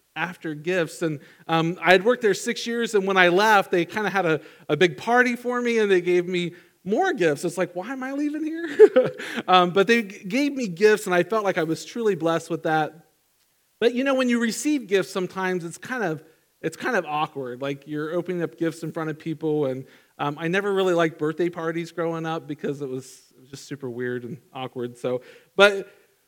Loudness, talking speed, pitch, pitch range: -23 LUFS, 230 wpm, 175 Hz, 160-215 Hz